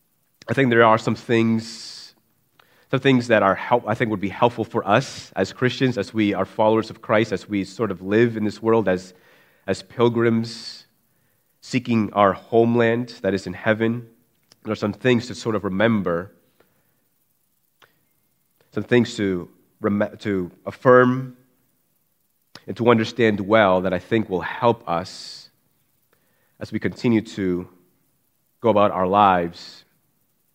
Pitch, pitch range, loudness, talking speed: 110 Hz, 100-115 Hz, -21 LUFS, 145 wpm